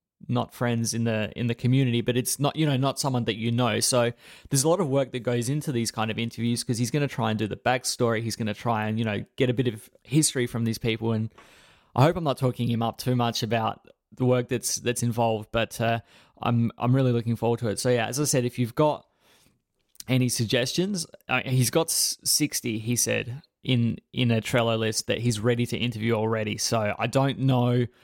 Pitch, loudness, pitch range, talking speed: 120 Hz, -25 LUFS, 115-130 Hz, 235 wpm